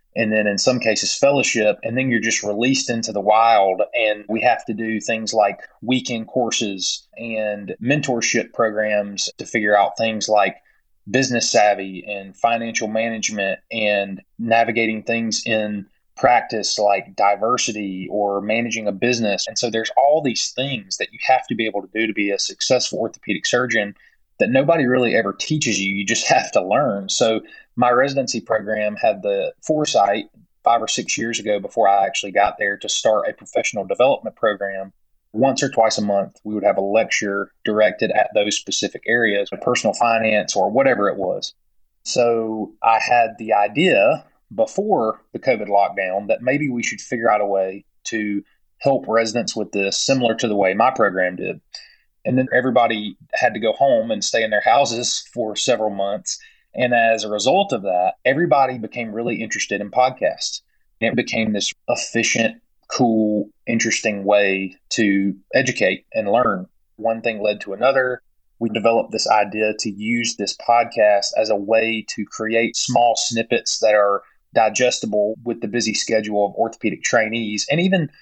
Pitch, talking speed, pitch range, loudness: 110 Hz, 170 wpm, 105-120 Hz, -19 LUFS